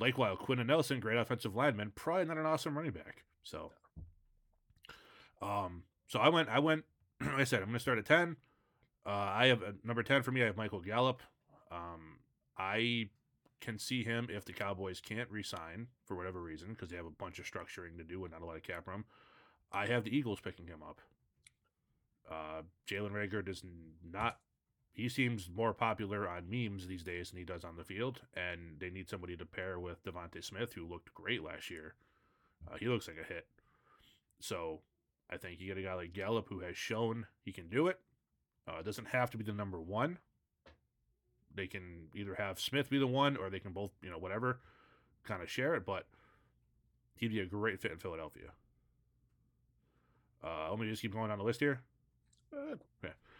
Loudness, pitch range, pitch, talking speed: -38 LUFS, 90-120 Hz, 105 Hz, 200 wpm